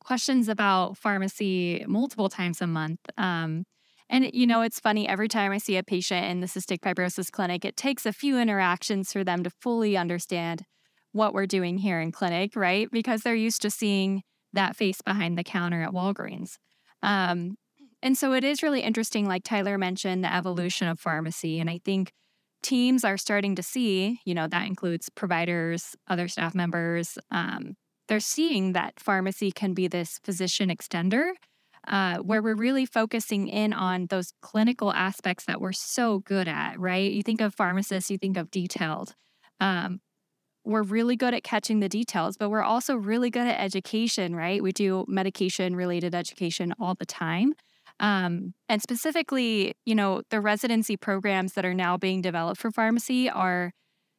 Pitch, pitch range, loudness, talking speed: 195 Hz, 180-220 Hz, -27 LUFS, 175 wpm